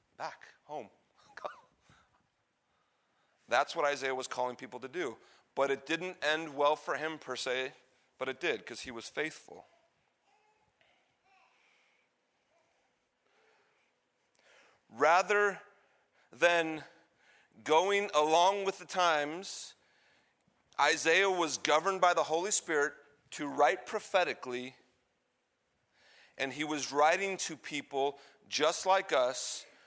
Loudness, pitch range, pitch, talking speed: -32 LUFS, 135-195 Hz, 160 Hz, 105 wpm